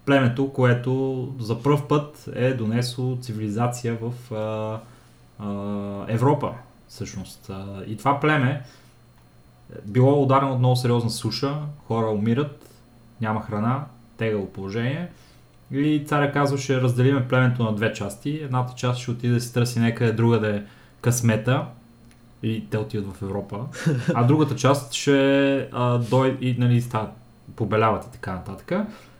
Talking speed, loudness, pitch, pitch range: 135 wpm, -23 LUFS, 120 Hz, 110-135 Hz